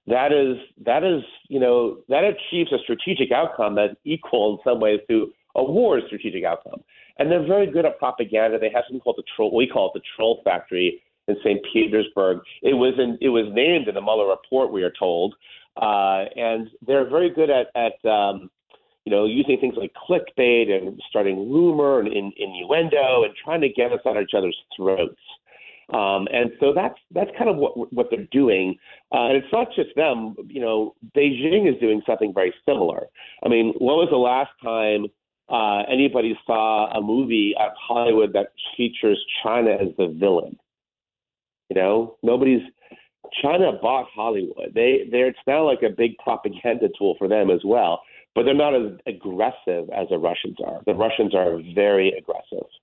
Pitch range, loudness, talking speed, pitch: 110-175 Hz, -21 LUFS, 185 wpm, 125 Hz